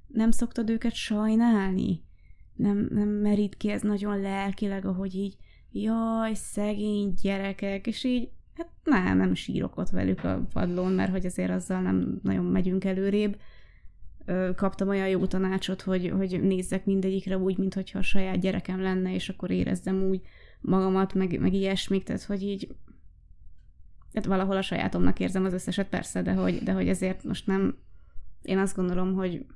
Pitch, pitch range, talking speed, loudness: 190 Hz, 175-200 Hz, 160 wpm, -28 LUFS